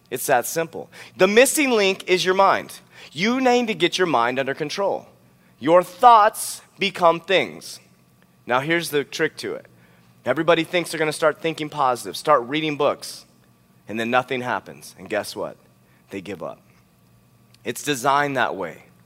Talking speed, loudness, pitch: 165 wpm, -20 LUFS, 150 Hz